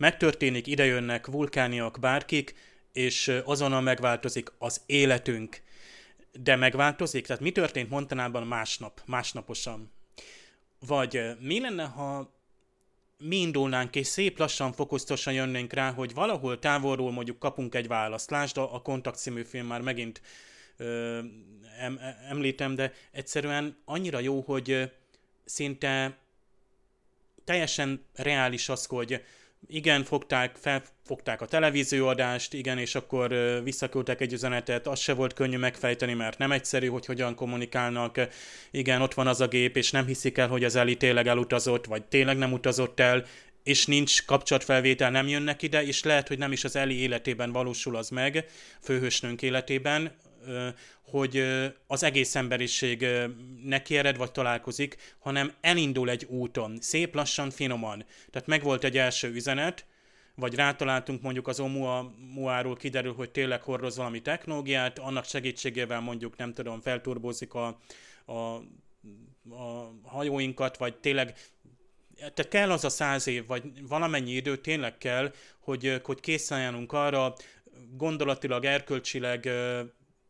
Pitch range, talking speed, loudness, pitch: 125-140 Hz, 130 wpm, -29 LUFS, 130 Hz